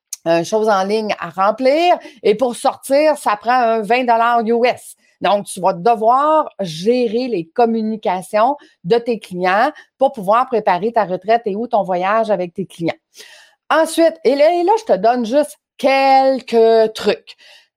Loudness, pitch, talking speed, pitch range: -16 LUFS, 235 Hz, 160 wpm, 210-270 Hz